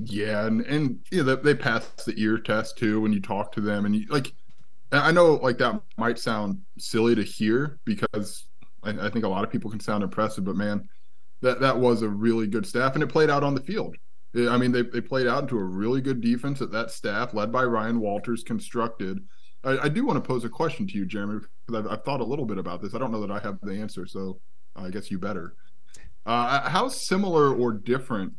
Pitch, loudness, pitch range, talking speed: 115 Hz, -26 LUFS, 105-130 Hz, 235 wpm